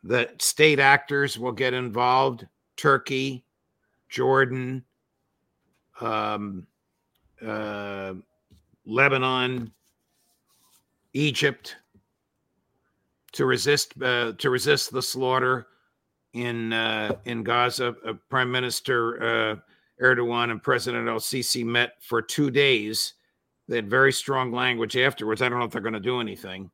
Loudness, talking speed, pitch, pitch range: -24 LUFS, 115 wpm, 125 Hz, 115-130 Hz